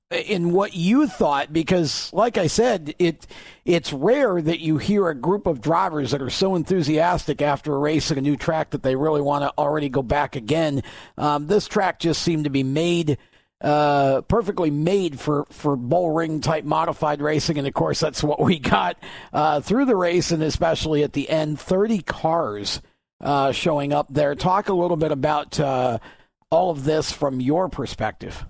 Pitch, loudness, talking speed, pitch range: 155 Hz, -21 LUFS, 190 wpm, 145-175 Hz